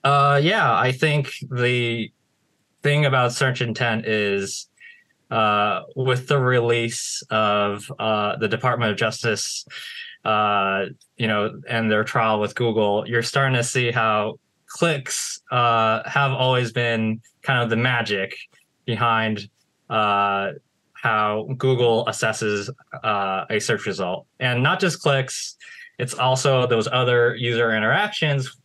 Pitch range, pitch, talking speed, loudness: 110-130 Hz, 120 Hz, 130 wpm, -21 LUFS